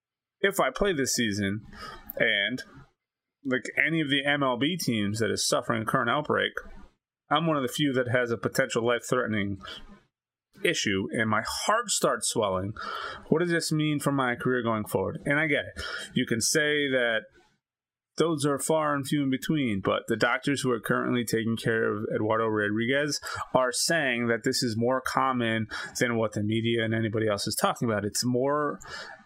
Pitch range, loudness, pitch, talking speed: 110-145 Hz, -27 LUFS, 125 Hz, 185 wpm